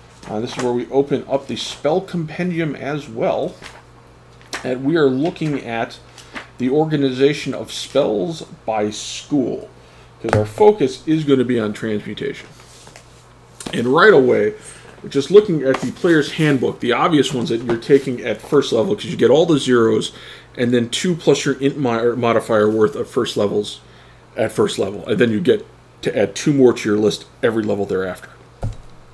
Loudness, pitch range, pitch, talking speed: -18 LUFS, 115-145 Hz, 130 Hz, 175 wpm